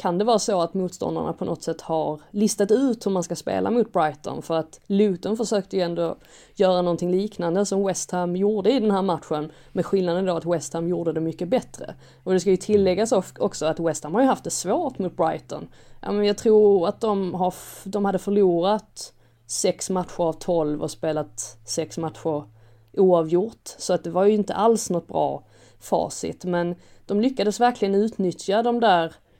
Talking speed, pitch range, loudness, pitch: 190 wpm, 165-205 Hz, -23 LUFS, 180 Hz